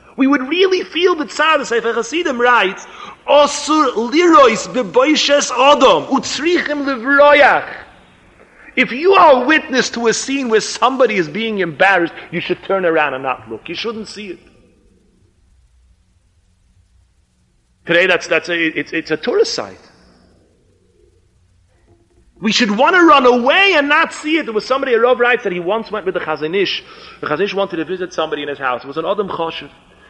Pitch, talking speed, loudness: 220 Hz, 165 wpm, -14 LUFS